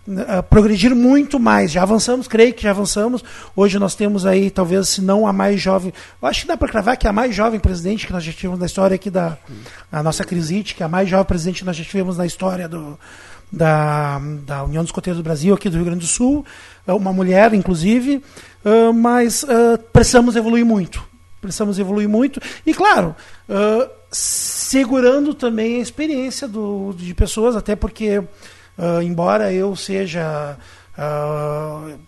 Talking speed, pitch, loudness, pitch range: 180 wpm, 200 Hz, -17 LUFS, 175-230 Hz